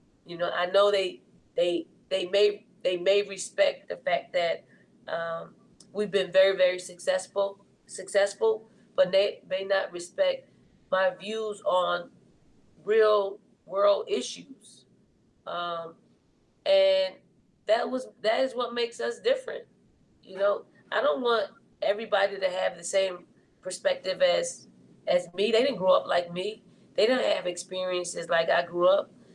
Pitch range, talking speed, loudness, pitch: 185-235 Hz, 145 wpm, -27 LUFS, 200 Hz